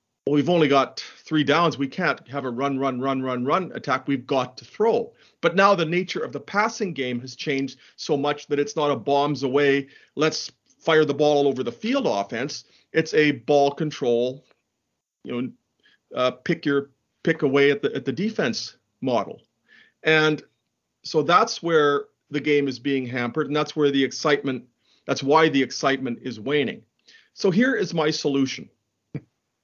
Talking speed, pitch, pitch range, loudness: 180 wpm, 145 Hz, 135-155 Hz, -23 LUFS